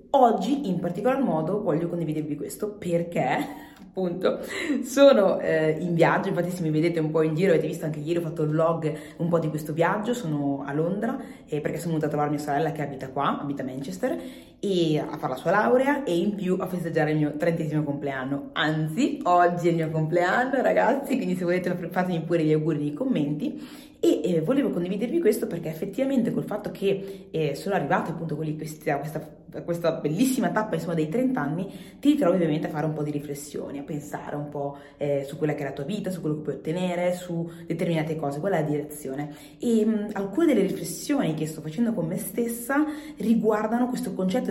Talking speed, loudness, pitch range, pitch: 205 wpm, -26 LUFS, 155-210 Hz, 170 Hz